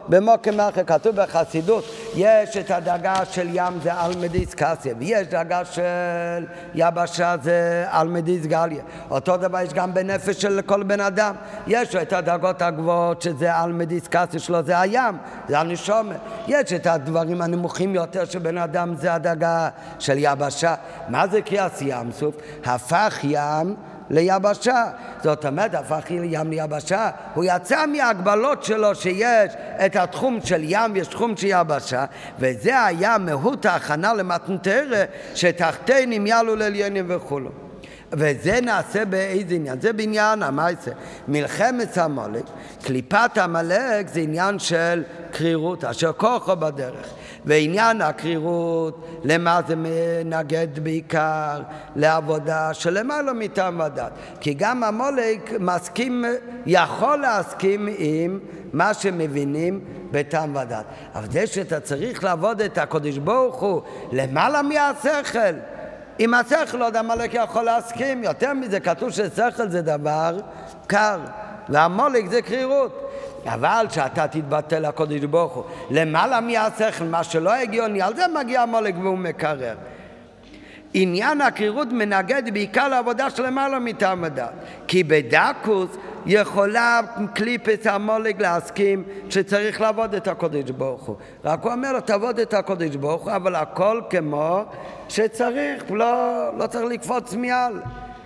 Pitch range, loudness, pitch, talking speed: 165-220 Hz, -21 LUFS, 185 Hz, 130 wpm